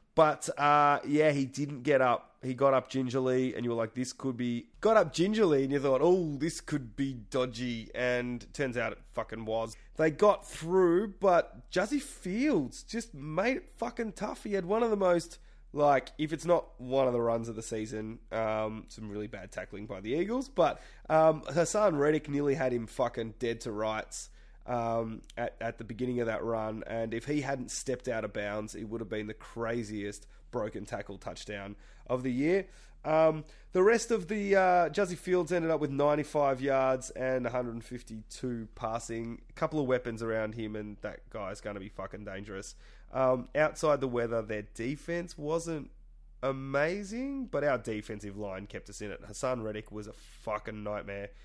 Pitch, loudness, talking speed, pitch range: 130 Hz, -31 LUFS, 190 wpm, 110-155 Hz